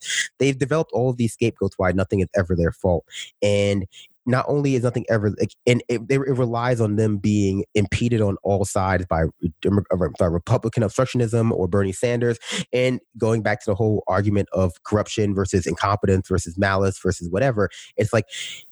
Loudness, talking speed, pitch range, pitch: -22 LUFS, 170 wpm, 95-120 Hz, 105 Hz